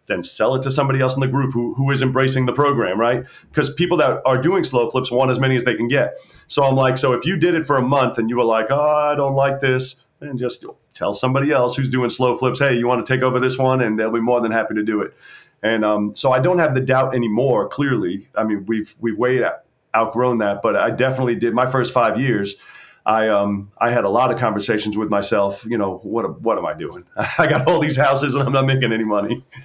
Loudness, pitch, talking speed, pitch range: -18 LUFS, 125 Hz, 260 wpm, 115-135 Hz